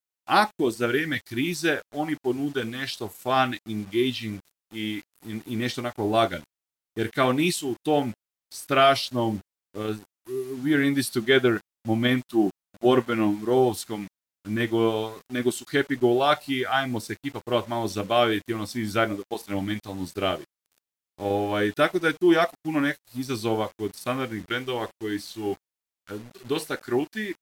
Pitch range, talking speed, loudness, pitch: 105-130 Hz, 140 wpm, -26 LUFS, 115 Hz